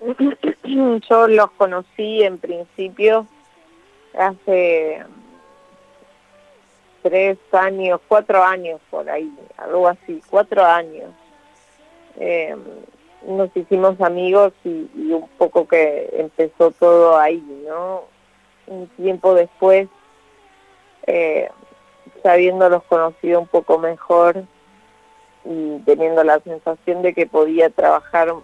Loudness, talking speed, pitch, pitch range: -16 LUFS, 100 wpm, 185 Hz, 170-215 Hz